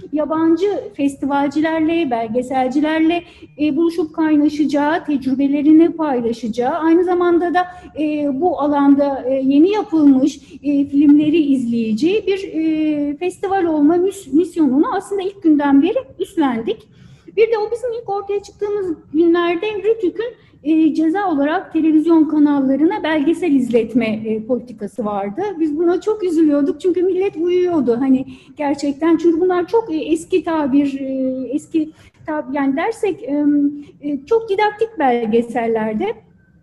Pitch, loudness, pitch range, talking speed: 315 Hz, -17 LUFS, 280-360 Hz, 125 wpm